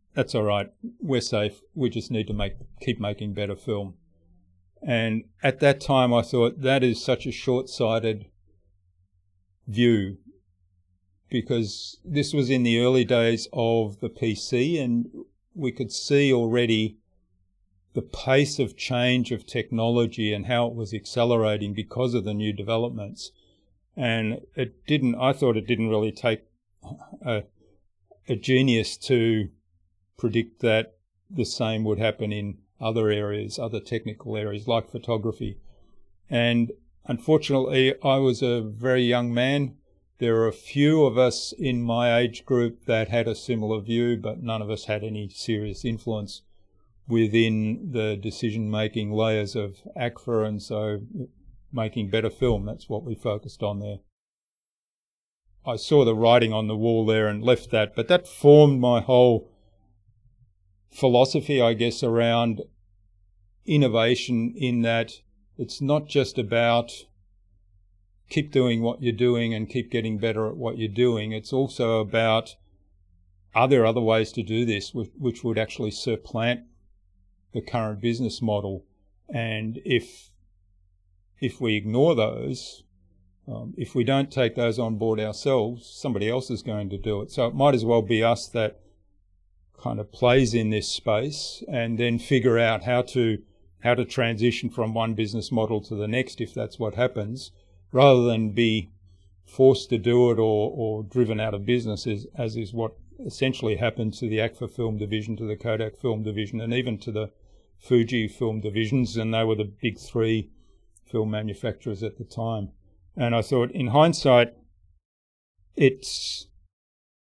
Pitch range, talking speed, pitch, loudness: 105-120 Hz, 150 wpm, 115 Hz, -24 LUFS